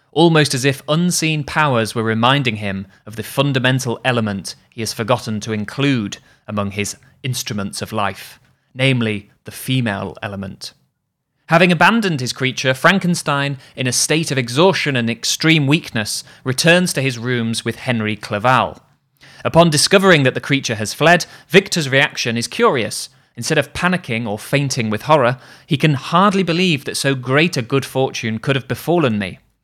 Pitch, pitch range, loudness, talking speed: 130 Hz, 115-150 Hz, -17 LUFS, 160 wpm